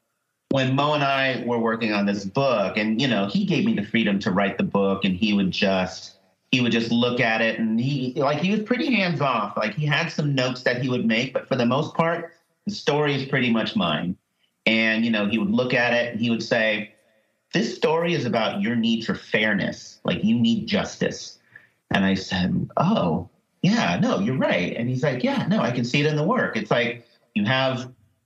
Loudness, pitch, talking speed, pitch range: -23 LUFS, 130 Hz, 225 wpm, 115-165 Hz